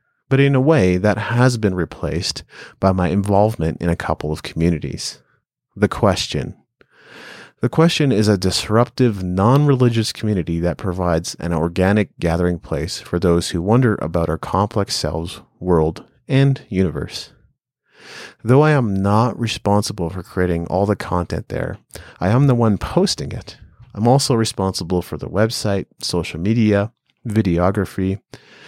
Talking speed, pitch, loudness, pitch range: 140 wpm, 100 Hz, -18 LUFS, 85-115 Hz